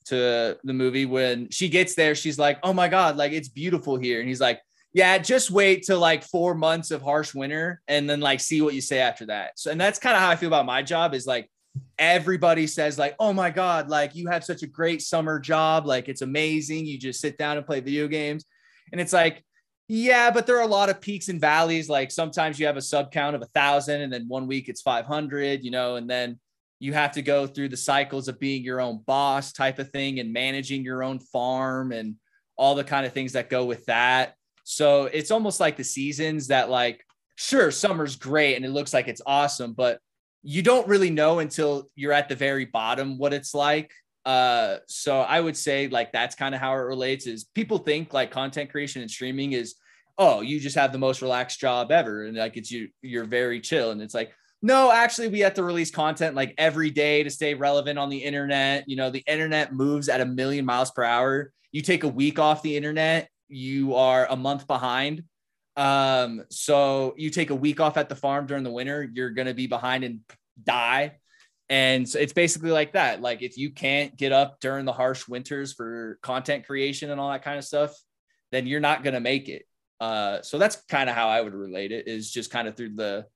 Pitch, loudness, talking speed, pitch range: 140 Hz, -24 LUFS, 225 wpm, 130-155 Hz